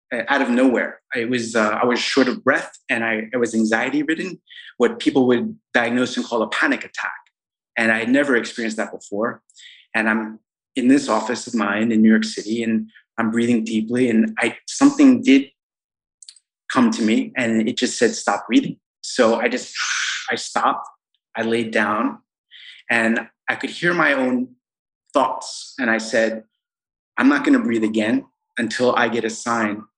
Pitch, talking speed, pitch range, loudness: 120 Hz, 180 wpm, 110-175 Hz, -20 LUFS